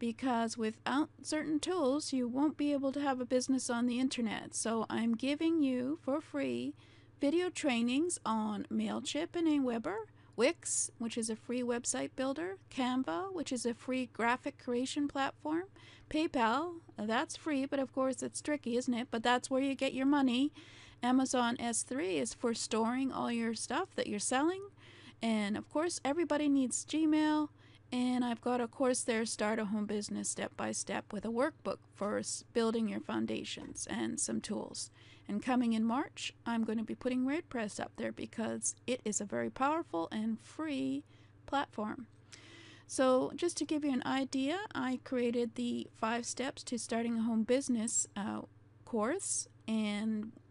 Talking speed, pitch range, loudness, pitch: 165 wpm, 230-285 Hz, -35 LUFS, 250 Hz